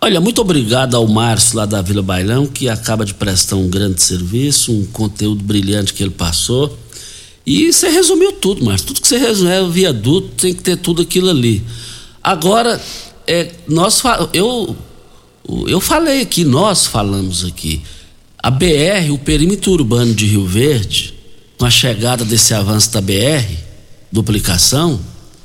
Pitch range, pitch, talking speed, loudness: 105-170 Hz, 120 Hz, 155 wpm, -13 LUFS